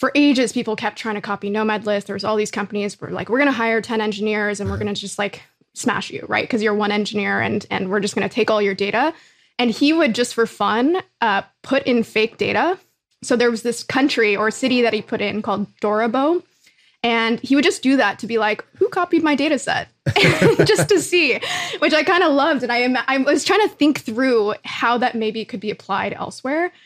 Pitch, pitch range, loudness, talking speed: 235 Hz, 210-280 Hz, -19 LUFS, 230 wpm